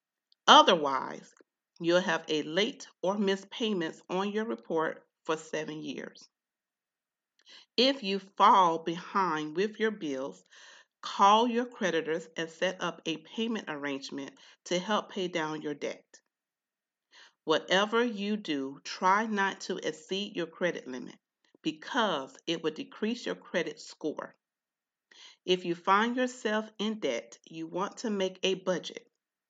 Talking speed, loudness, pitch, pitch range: 130 wpm, -30 LUFS, 190 Hz, 165-215 Hz